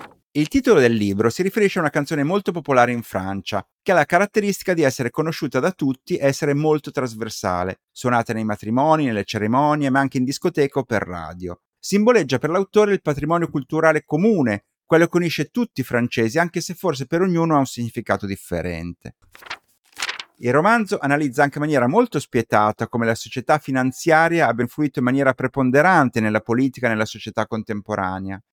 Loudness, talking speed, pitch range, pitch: -20 LUFS, 175 wpm, 115-160 Hz, 135 Hz